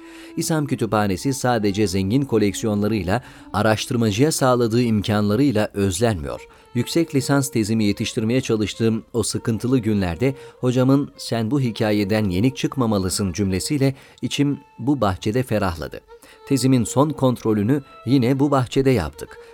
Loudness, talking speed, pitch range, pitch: -21 LUFS, 110 wpm, 105-140 Hz, 120 Hz